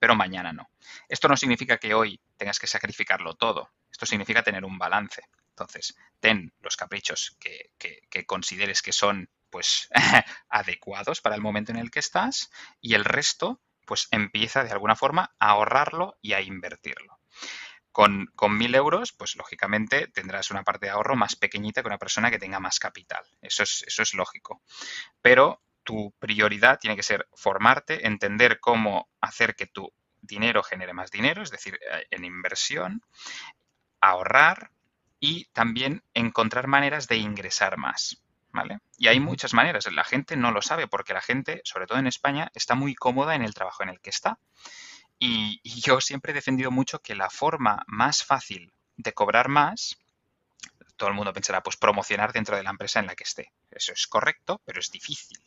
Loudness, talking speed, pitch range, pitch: -24 LUFS, 175 wpm, 105-135 Hz, 115 Hz